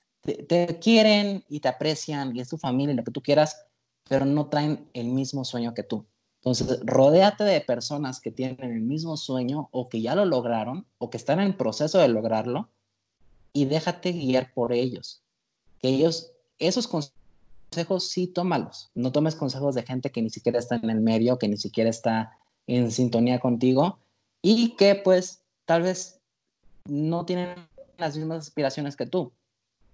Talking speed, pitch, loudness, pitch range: 170 wpm, 140 Hz, -25 LUFS, 120-170 Hz